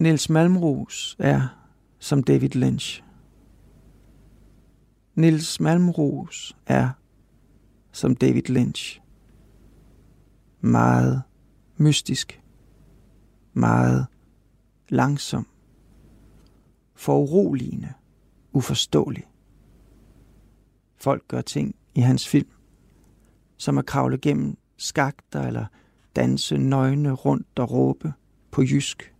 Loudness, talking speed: -23 LUFS, 75 wpm